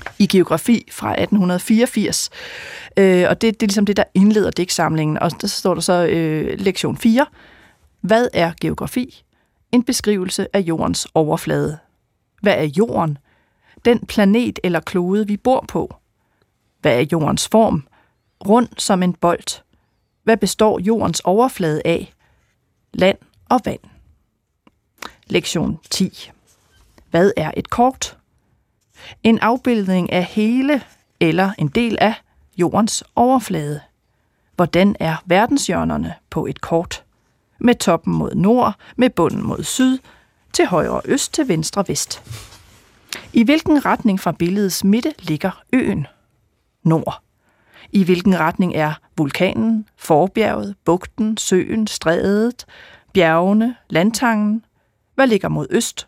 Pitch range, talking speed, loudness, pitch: 165-225 Hz, 125 wpm, -18 LUFS, 195 Hz